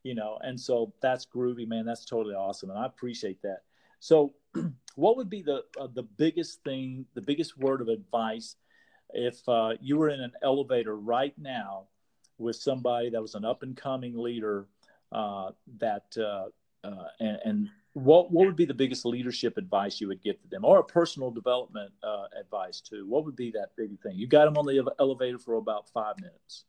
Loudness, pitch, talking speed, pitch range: -29 LUFS, 125 Hz, 195 wpm, 115-145 Hz